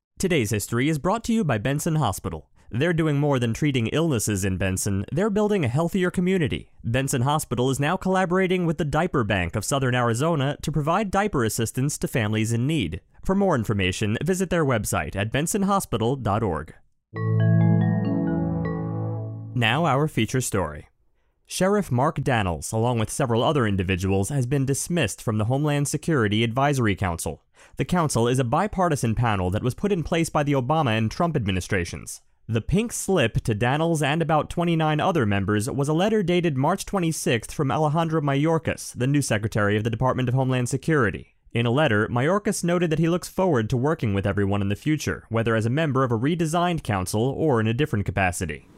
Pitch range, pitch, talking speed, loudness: 110-160 Hz, 135 Hz, 180 wpm, -23 LUFS